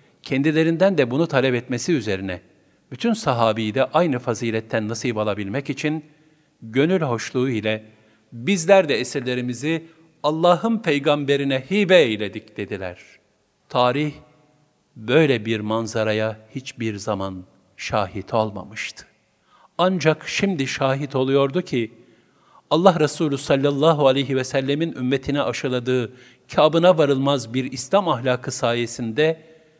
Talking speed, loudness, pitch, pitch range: 105 wpm, -21 LUFS, 135 Hz, 115-155 Hz